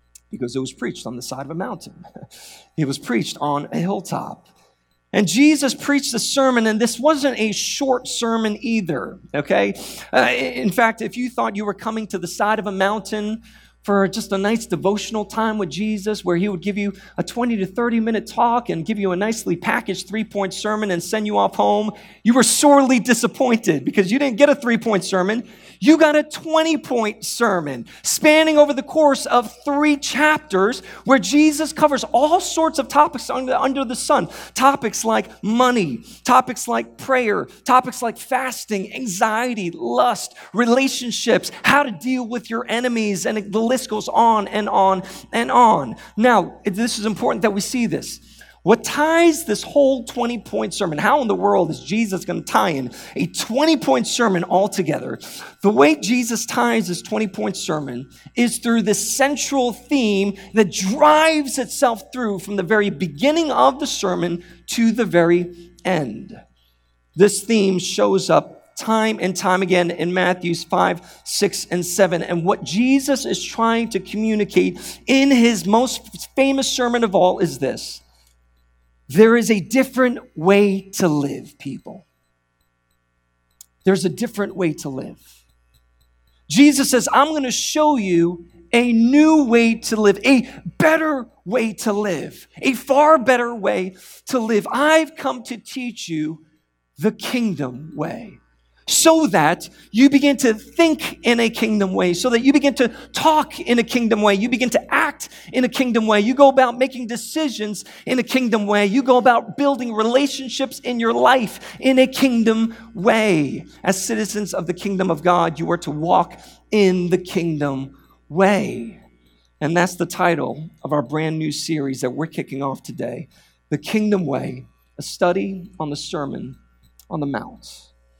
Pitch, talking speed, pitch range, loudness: 215 Hz, 170 wpm, 180-250 Hz, -18 LUFS